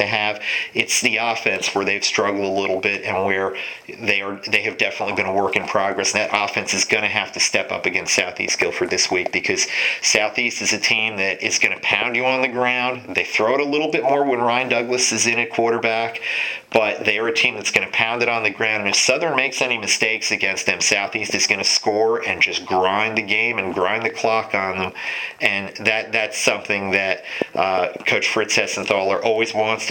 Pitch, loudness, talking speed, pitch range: 110 Hz, -19 LUFS, 225 wpm, 100-120 Hz